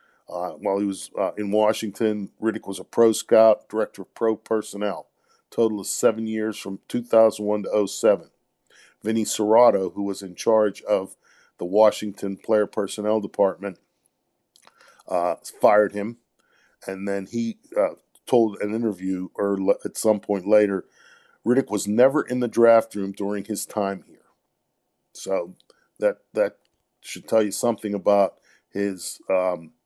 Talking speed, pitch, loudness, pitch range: 145 wpm, 105 Hz, -23 LUFS, 100-110 Hz